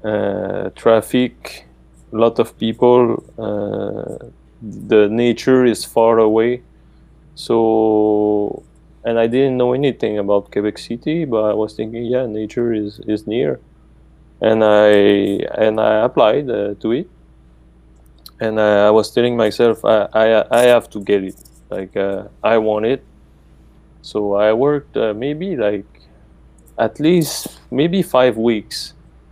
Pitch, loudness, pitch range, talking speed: 110 Hz, -16 LUFS, 100-120 Hz, 135 wpm